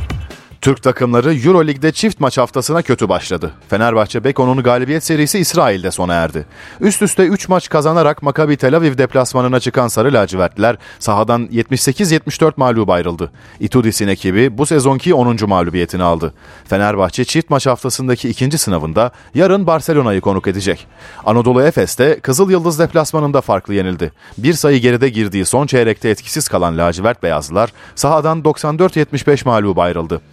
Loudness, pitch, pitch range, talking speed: -14 LUFS, 125 Hz, 100-155 Hz, 135 wpm